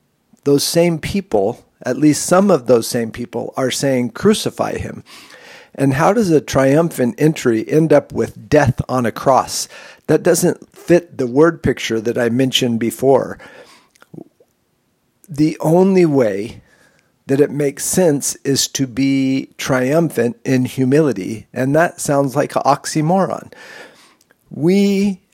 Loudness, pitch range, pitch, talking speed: -16 LUFS, 130-160 Hz, 140 Hz, 135 wpm